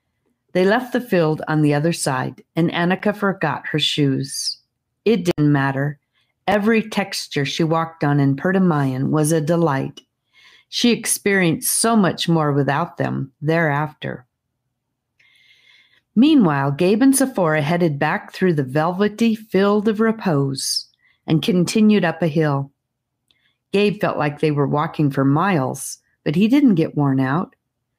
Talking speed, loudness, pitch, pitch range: 140 wpm, -19 LUFS, 160 Hz, 140-195 Hz